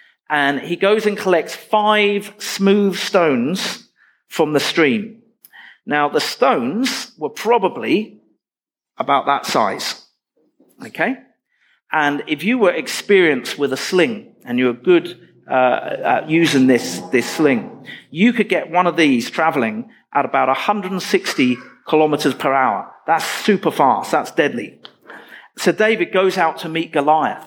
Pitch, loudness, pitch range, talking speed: 180 Hz, -17 LUFS, 145-215 Hz, 140 wpm